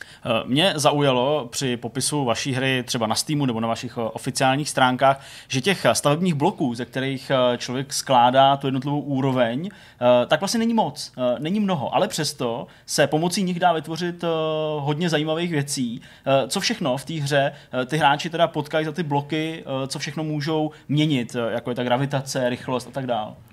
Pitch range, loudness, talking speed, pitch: 130-155 Hz, -22 LUFS, 165 wpm, 140 Hz